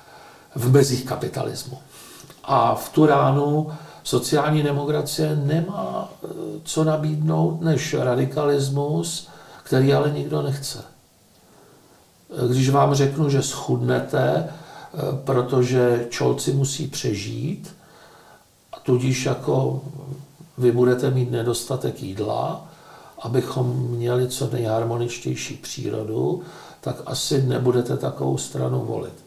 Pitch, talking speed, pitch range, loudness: 135 Hz, 95 wpm, 125-150 Hz, -22 LUFS